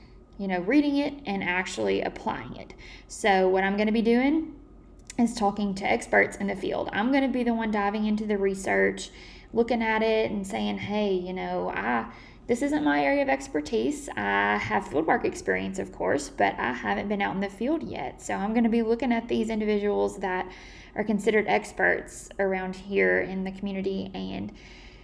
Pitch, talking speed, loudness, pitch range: 200 Hz, 185 wpm, -26 LUFS, 150-225 Hz